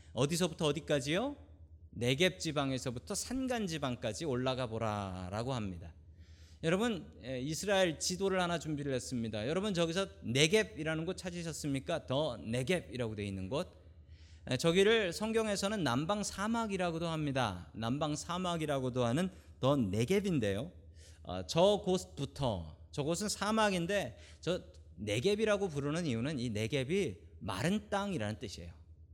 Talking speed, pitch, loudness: 315 characters per minute, 140 Hz, -35 LUFS